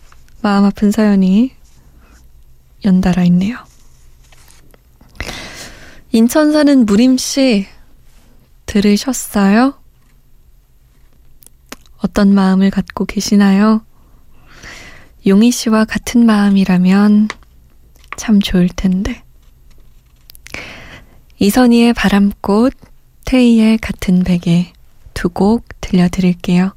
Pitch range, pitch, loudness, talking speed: 180-220 Hz, 200 Hz, -12 LUFS, 165 characters per minute